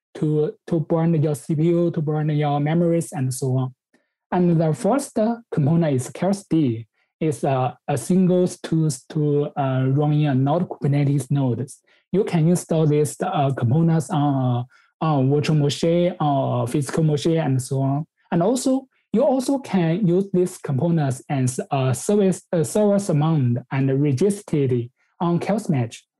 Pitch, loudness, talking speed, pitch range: 155 Hz, -21 LUFS, 150 wpm, 140-175 Hz